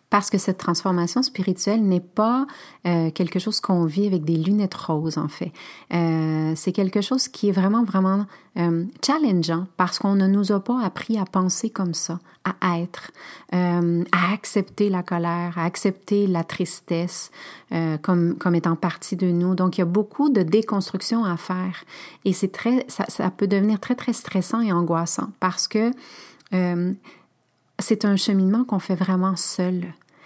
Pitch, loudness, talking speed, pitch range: 190 Hz, -22 LUFS, 175 wpm, 175-205 Hz